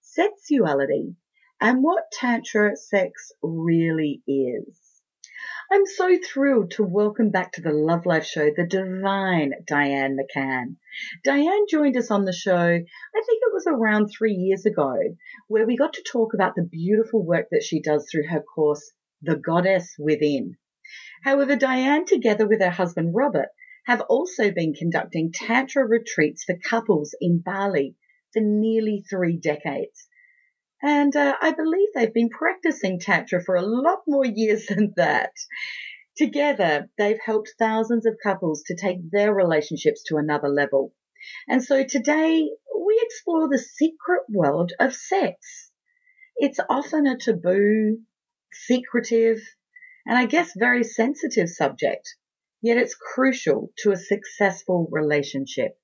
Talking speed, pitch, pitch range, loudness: 140 wpm, 220 Hz, 175-285 Hz, -22 LUFS